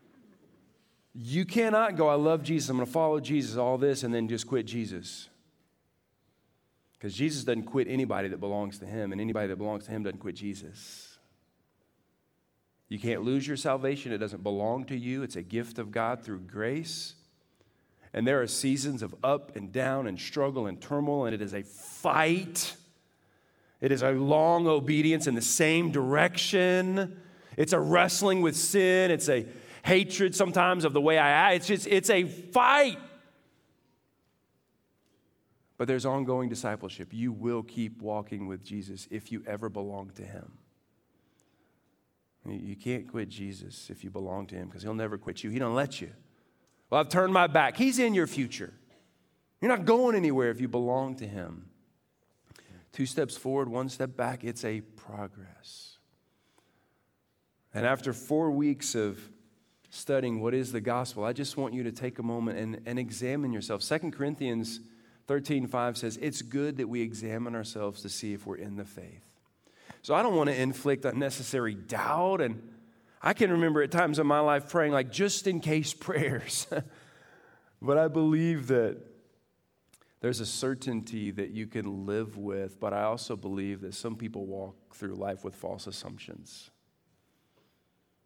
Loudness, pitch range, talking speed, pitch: -29 LUFS, 105-150 Hz, 165 wpm, 125 Hz